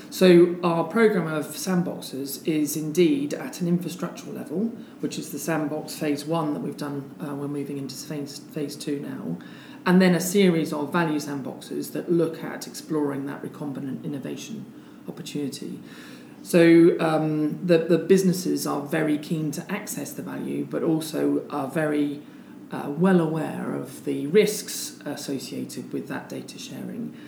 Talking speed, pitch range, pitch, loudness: 155 wpm, 145-175 Hz, 155 Hz, -25 LUFS